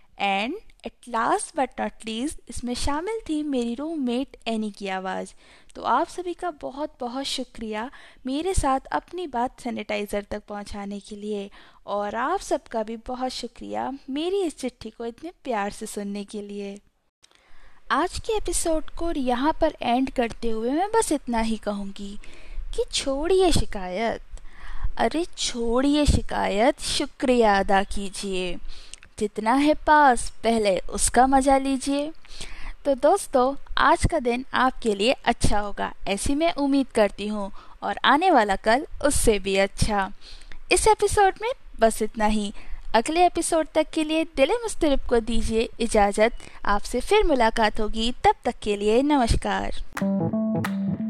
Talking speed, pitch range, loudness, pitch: 145 wpm, 210-305 Hz, -24 LUFS, 245 Hz